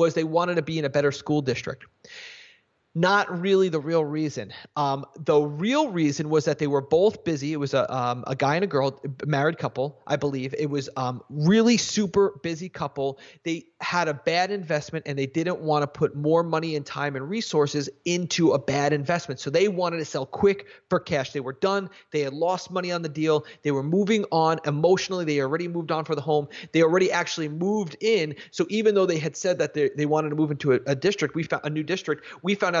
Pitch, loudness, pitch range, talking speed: 160 Hz, -25 LUFS, 145-180 Hz, 230 wpm